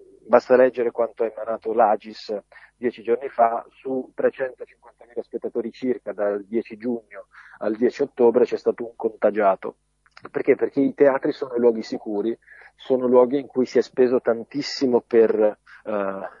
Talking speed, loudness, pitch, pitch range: 145 wpm, -22 LUFS, 125 Hz, 115-140 Hz